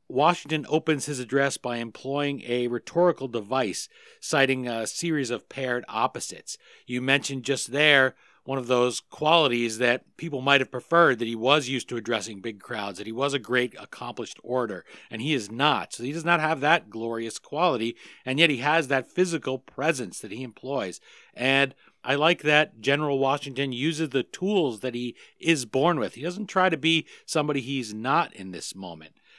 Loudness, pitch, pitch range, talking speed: -25 LUFS, 135 Hz, 120-155 Hz, 185 wpm